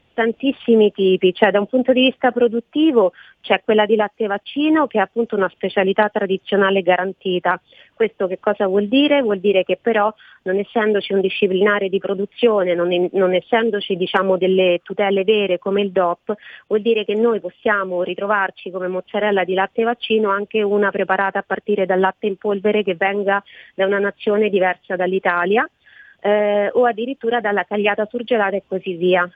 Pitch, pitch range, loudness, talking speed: 200 Hz, 190-220 Hz, -18 LUFS, 170 wpm